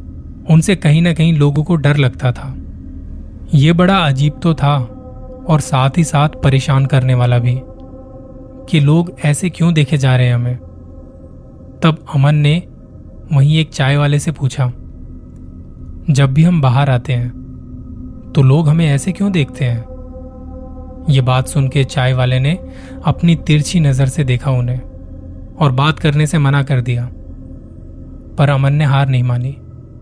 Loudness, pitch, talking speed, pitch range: -14 LUFS, 130 Hz, 160 wpm, 95-150 Hz